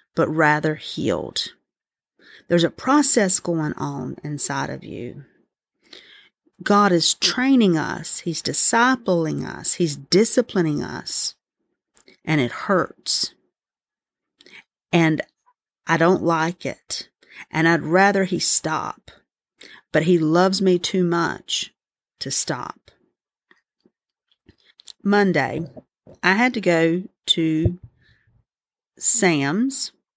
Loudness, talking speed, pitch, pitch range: -20 LUFS, 95 wpm, 170 Hz, 155-195 Hz